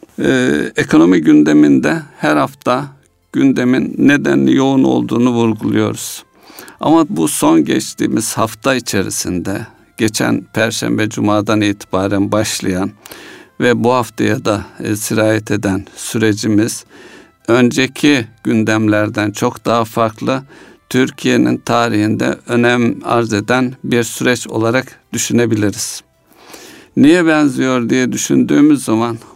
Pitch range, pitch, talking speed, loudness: 105-125 Hz, 115 Hz, 95 wpm, -14 LUFS